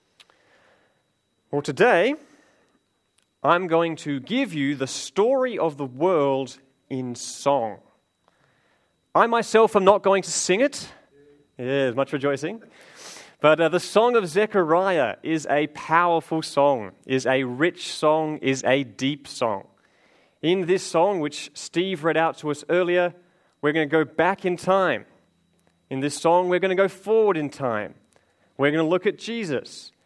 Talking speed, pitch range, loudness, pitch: 155 wpm, 140-185 Hz, -22 LUFS, 160 Hz